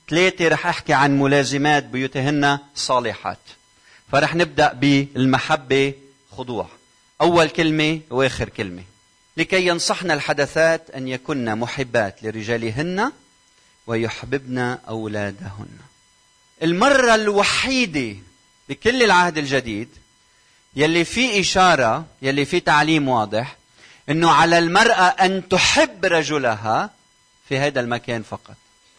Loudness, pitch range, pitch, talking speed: -19 LUFS, 120-165 Hz, 140 Hz, 95 wpm